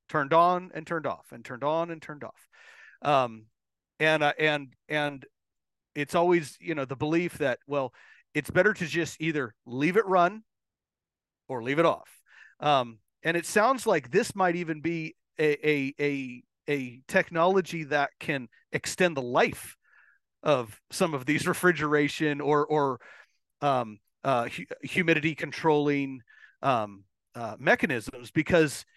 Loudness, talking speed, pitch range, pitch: -27 LUFS, 145 wpm, 135-170 Hz, 150 Hz